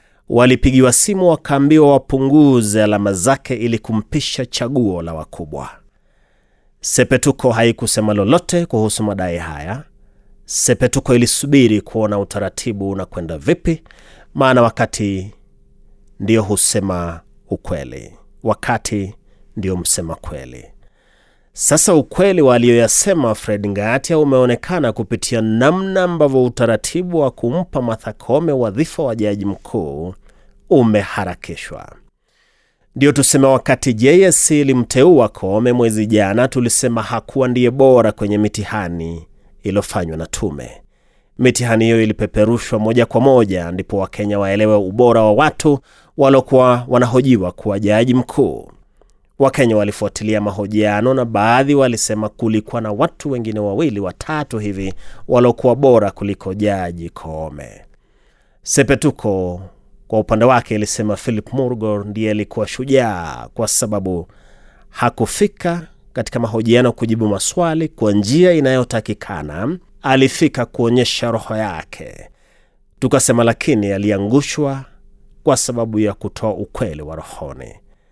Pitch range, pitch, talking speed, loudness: 105-130 Hz, 115 Hz, 105 wpm, -15 LUFS